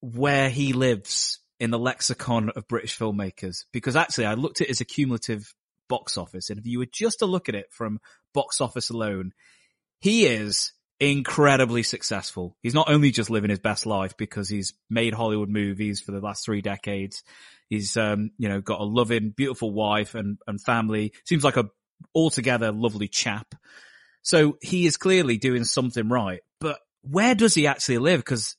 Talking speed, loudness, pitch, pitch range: 180 wpm, -24 LUFS, 115 Hz, 105-135 Hz